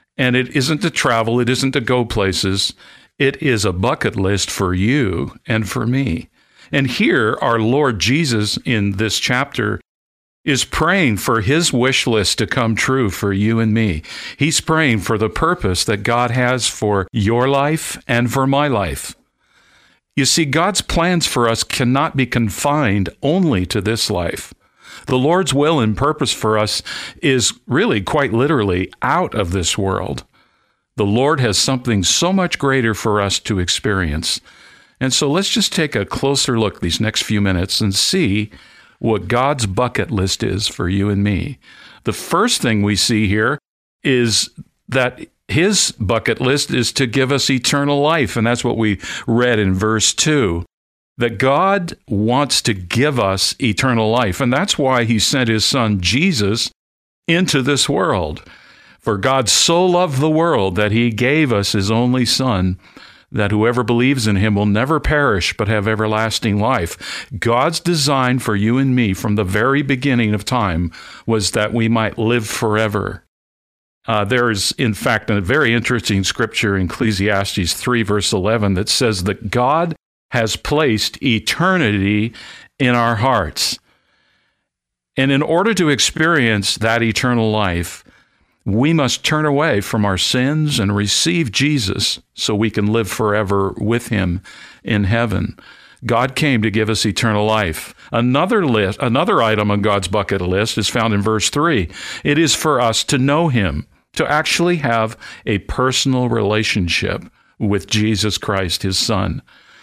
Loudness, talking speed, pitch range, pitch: -16 LUFS, 160 wpm, 105-135 Hz, 115 Hz